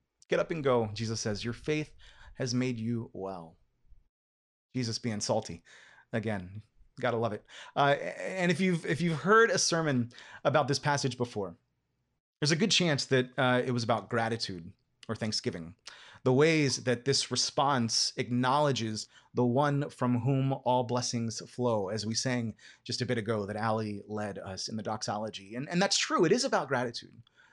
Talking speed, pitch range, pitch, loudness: 170 wpm, 110-135 Hz, 120 Hz, -30 LUFS